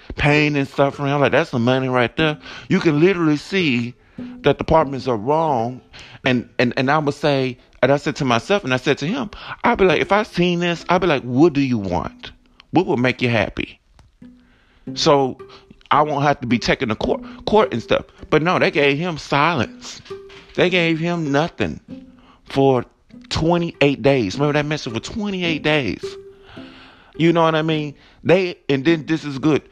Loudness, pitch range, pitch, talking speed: -19 LUFS, 135-175 Hz, 150 Hz, 195 wpm